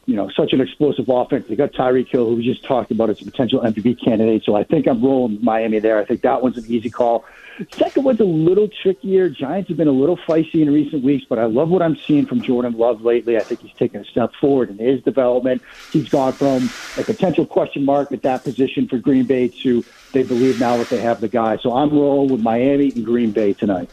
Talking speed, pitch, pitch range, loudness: 250 wpm, 130 Hz, 120-140 Hz, -18 LUFS